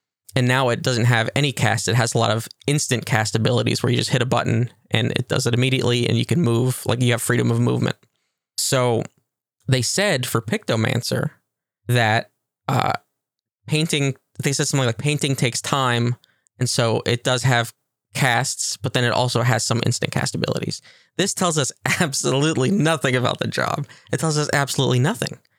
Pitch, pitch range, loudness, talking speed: 125 Hz, 115-140 Hz, -20 LUFS, 185 wpm